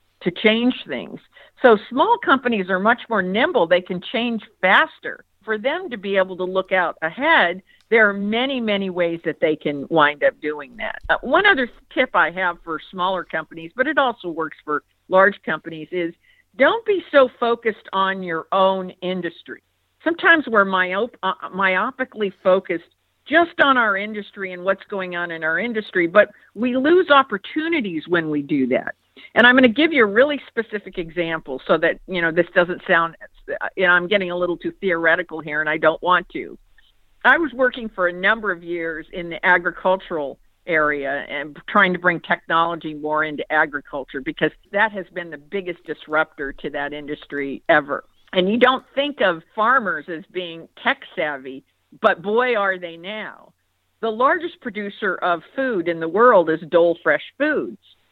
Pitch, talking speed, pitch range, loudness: 185 Hz, 180 wpm, 165-230 Hz, -20 LUFS